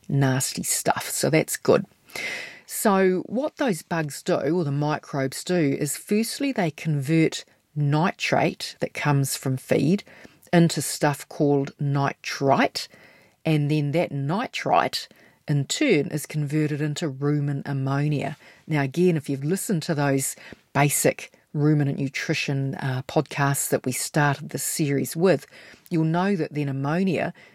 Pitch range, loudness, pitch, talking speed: 140-170 Hz, -24 LUFS, 150 Hz, 135 wpm